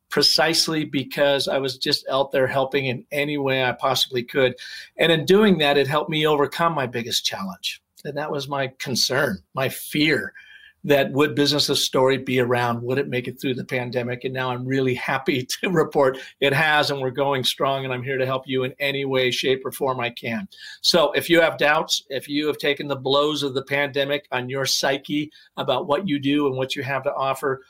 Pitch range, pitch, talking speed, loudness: 130-145 Hz, 140 Hz, 215 wpm, -21 LUFS